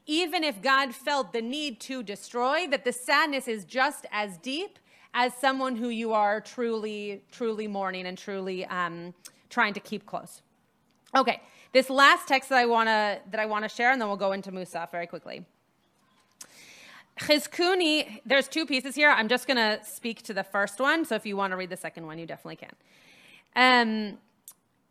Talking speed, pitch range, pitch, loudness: 180 wpm, 200-270 Hz, 230 Hz, -26 LUFS